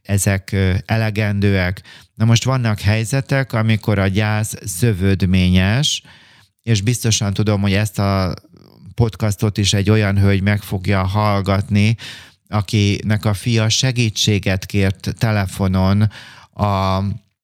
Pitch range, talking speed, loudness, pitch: 100-110 Hz, 105 wpm, -17 LUFS, 105 Hz